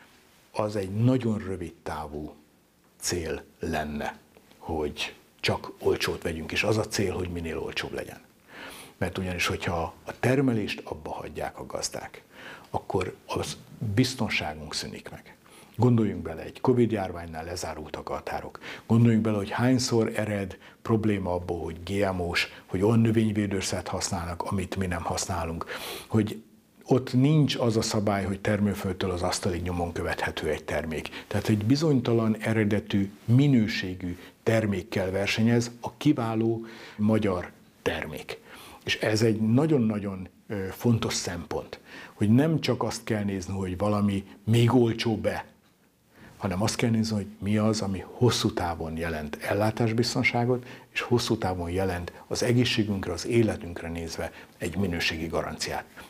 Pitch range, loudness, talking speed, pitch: 90-115 Hz, -27 LUFS, 130 wpm, 105 Hz